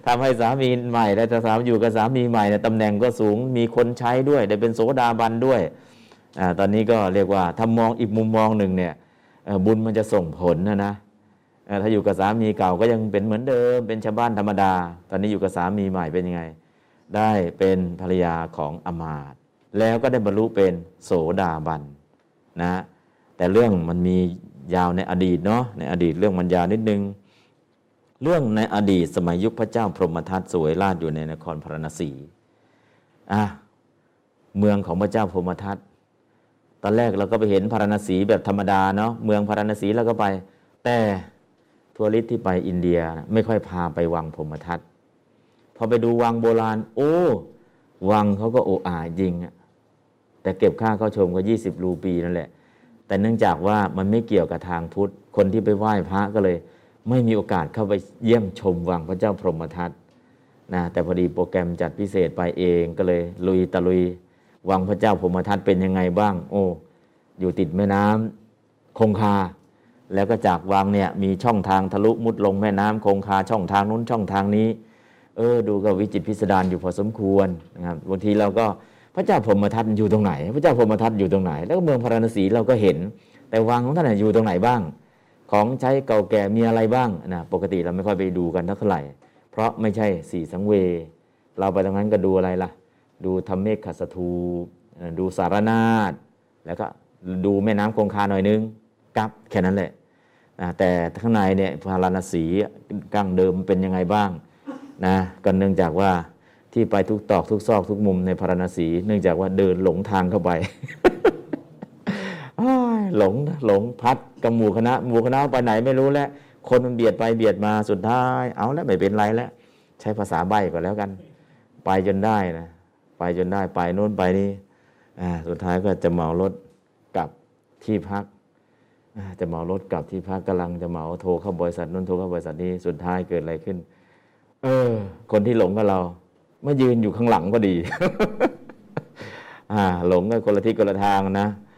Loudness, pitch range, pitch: -22 LUFS, 90-110 Hz, 100 Hz